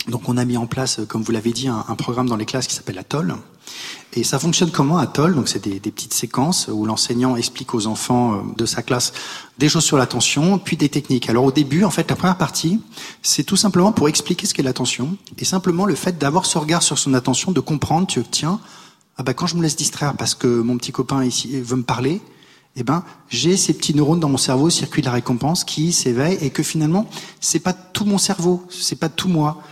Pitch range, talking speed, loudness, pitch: 125-170 Hz, 240 wpm, -19 LUFS, 145 Hz